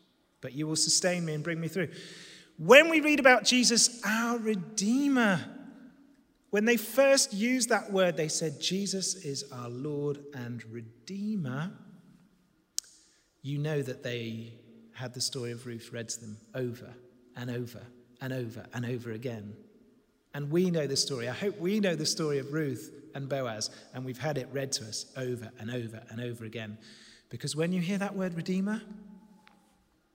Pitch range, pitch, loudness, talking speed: 125-200 Hz, 155 Hz, -29 LUFS, 170 wpm